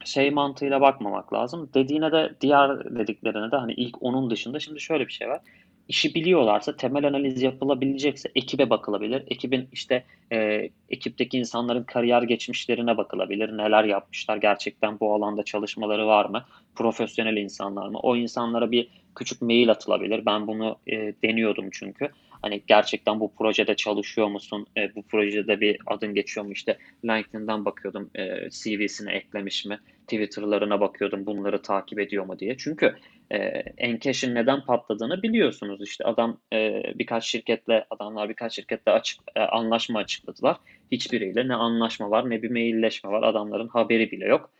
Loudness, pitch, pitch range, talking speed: -25 LUFS, 115 Hz, 105-125 Hz, 150 wpm